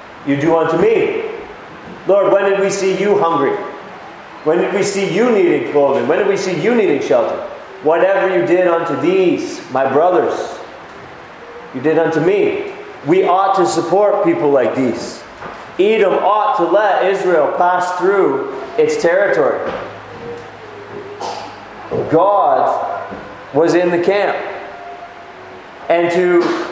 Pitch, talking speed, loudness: 195 Hz, 135 wpm, -15 LUFS